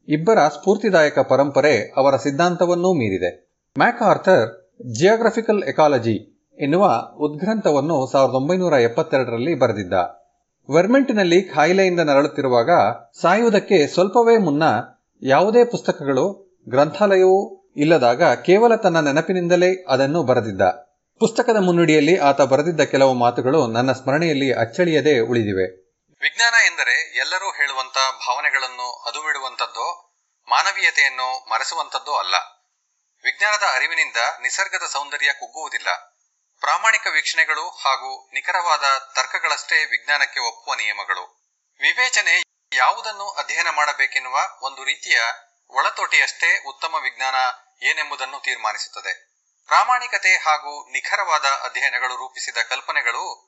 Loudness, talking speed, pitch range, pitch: -18 LUFS, 90 wpm, 135-195 Hz, 155 Hz